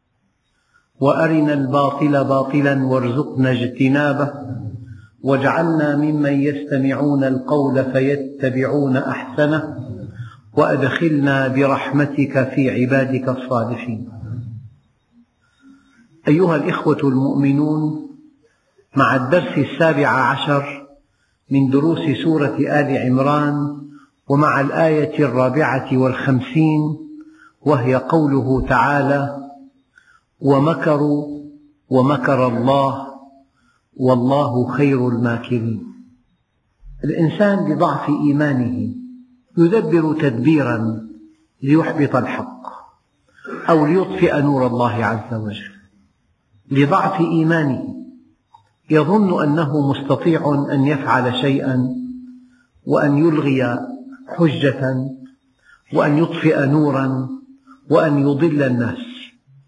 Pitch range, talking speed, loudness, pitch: 130-155 Hz, 70 wpm, -17 LUFS, 140 Hz